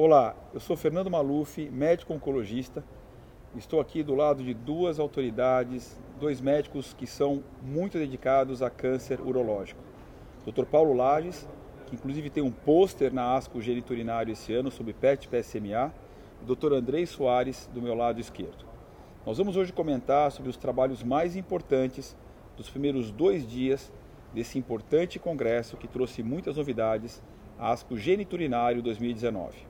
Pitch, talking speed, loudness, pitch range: 130 Hz, 145 wpm, -29 LUFS, 120-150 Hz